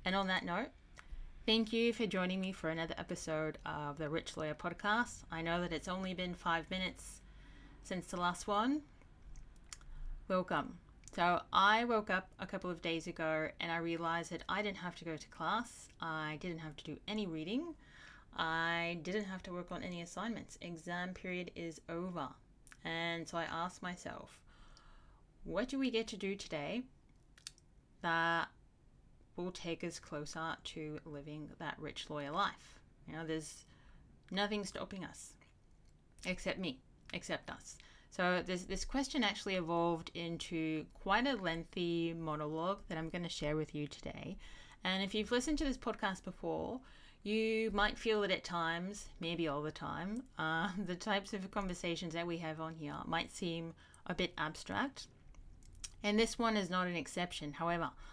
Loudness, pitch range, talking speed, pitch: -39 LUFS, 165-200 Hz, 165 wpm, 175 Hz